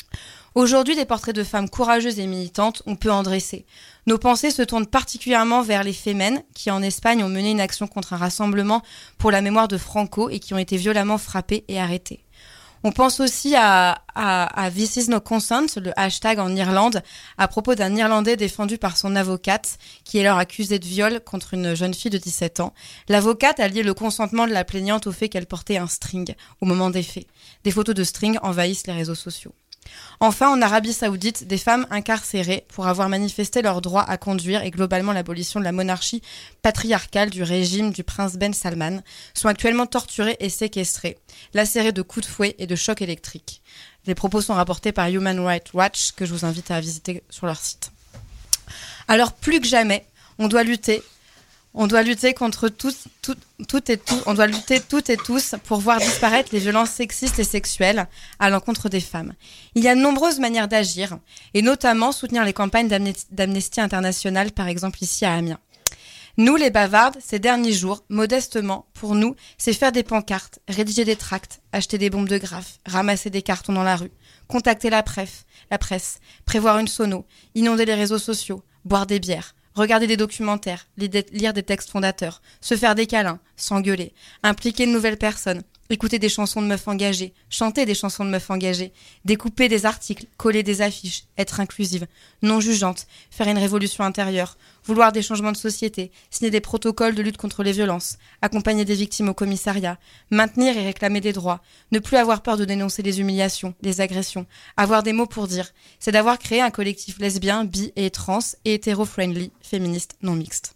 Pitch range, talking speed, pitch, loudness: 190-225 Hz, 190 wpm, 205 Hz, -21 LUFS